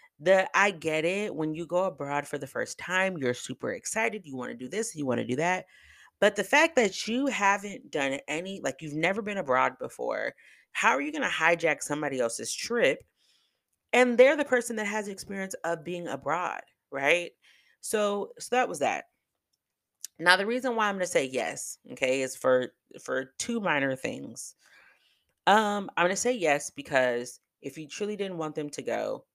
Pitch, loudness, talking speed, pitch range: 185 Hz, -28 LUFS, 195 wpm, 145-215 Hz